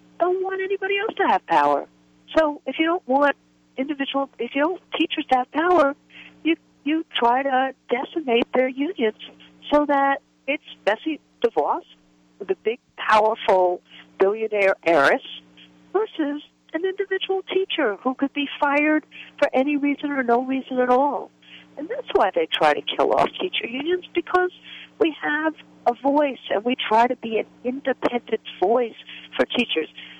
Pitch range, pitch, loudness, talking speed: 235-320 Hz, 275 Hz, -22 LUFS, 155 wpm